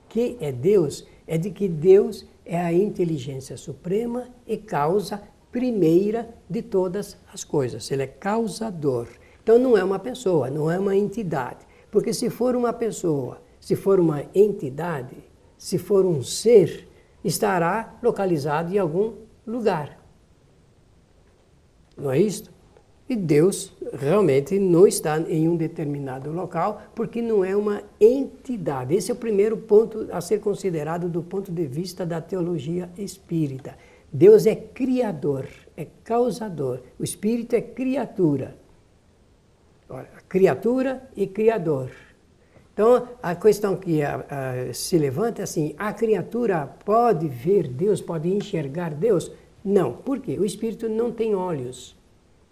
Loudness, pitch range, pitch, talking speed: -23 LUFS, 155-220 Hz, 190 Hz, 135 wpm